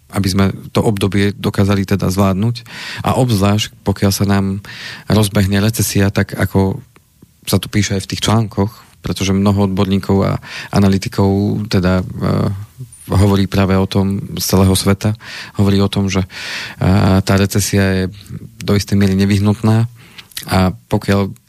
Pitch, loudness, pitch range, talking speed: 100 Hz, -15 LUFS, 95-105 Hz, 140 wpm